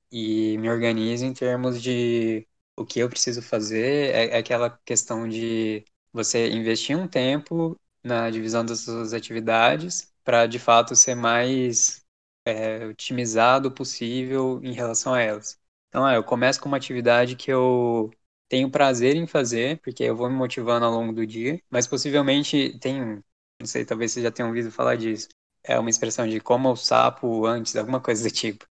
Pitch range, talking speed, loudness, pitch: 115-130 Hz, 170 wpm, -23 LUFS, 120 Hz